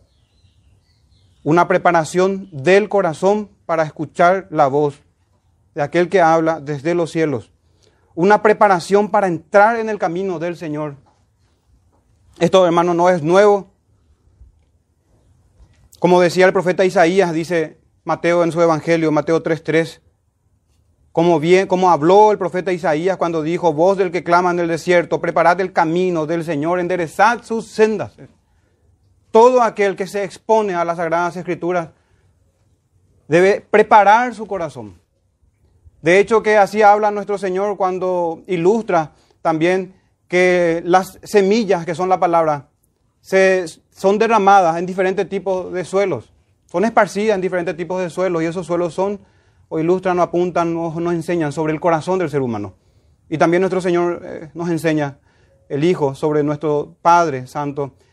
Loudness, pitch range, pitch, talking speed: -16 LUFS, 140-185 Hz, 170 Hz, 145 wpm